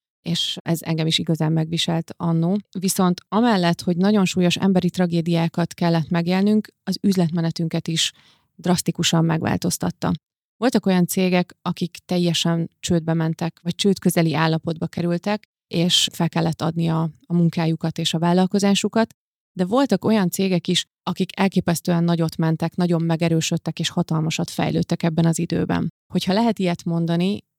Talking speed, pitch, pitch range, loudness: 135 wpm, 170 Hz, 165-185 Hz, -21 LUFS